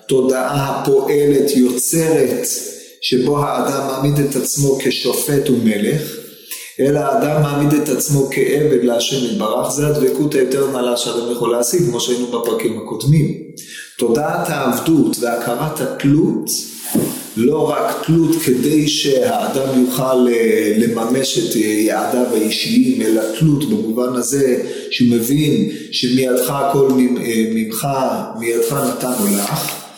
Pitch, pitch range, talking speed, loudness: 130 Hz, 120-145 Hz, 110 wpm, -16 LUFS